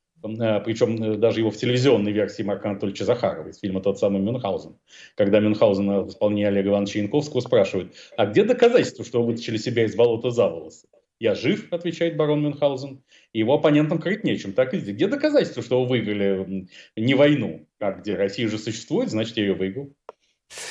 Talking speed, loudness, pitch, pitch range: 175 wpm, -22 LUFS, 115 Hz, 105-140 Hz